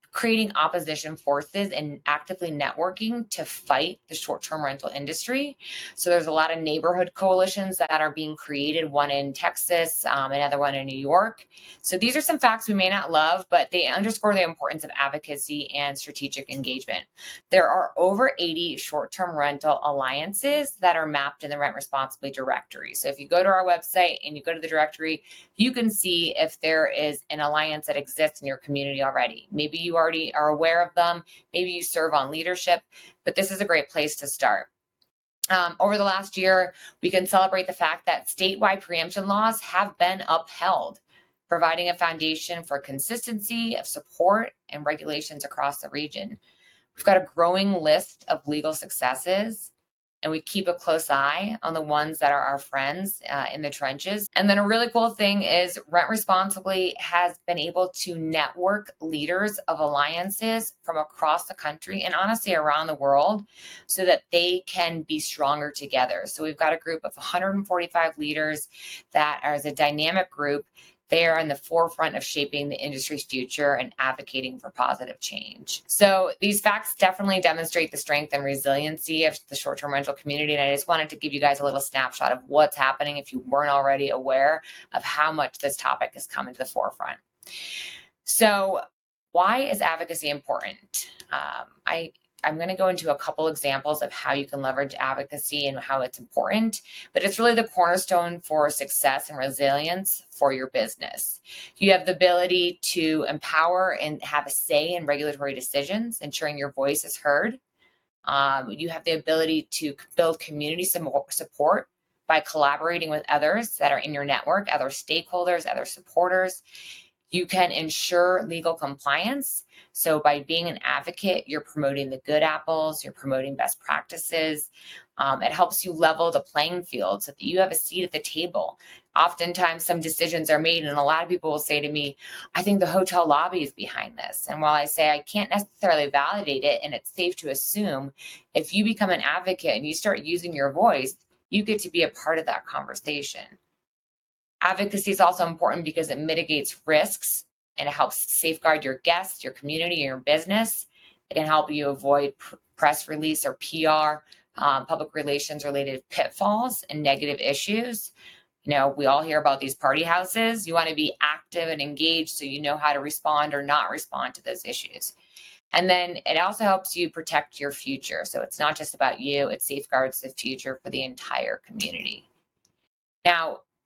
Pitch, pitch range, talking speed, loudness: 160 Hz, 145-180 Hz, 185 wpm, -25 LUFS